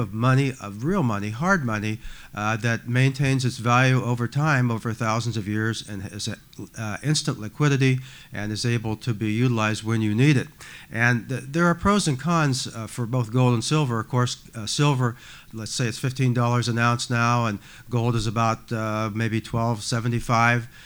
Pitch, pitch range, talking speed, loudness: 120 Hz, 110-130 Hz, 185 wpm, -23 LUFS